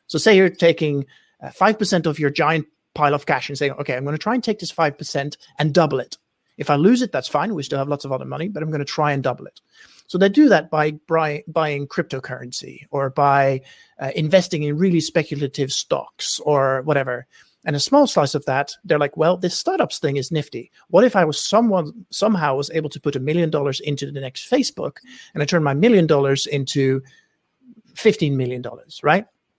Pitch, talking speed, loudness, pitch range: 150 Hz, 220 wpm, -20 LUFS, 140-175 Hz